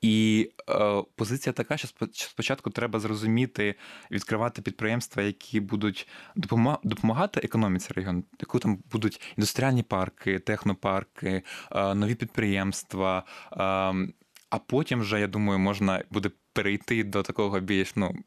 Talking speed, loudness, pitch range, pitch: 125 wpm, -28 LUFS, 95-115 Hz, 105 Hz